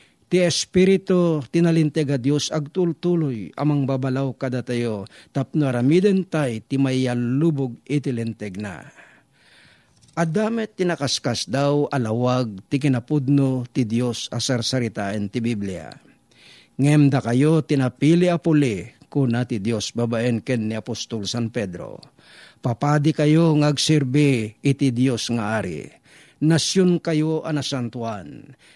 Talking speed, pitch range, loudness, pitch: 105 wpm, 120-155 Hz, -21 LUFS, 135 Hz